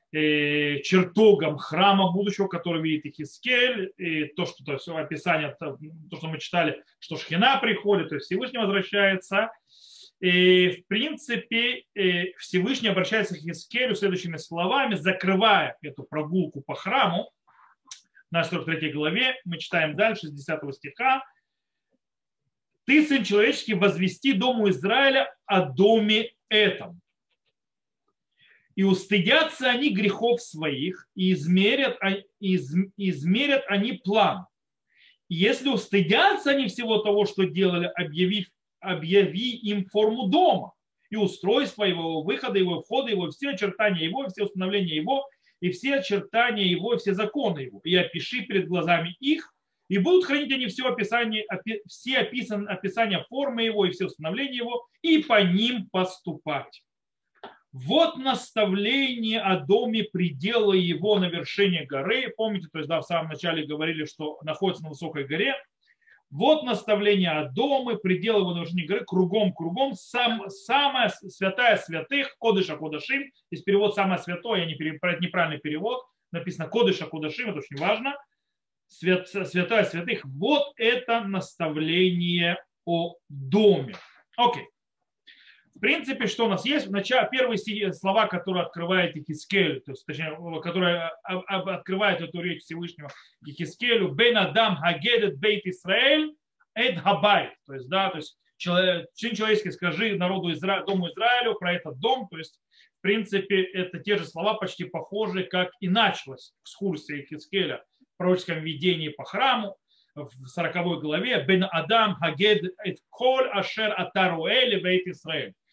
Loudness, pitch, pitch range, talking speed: -25 LUFS, 195 Hz, 170-225 Hz, 135 wpm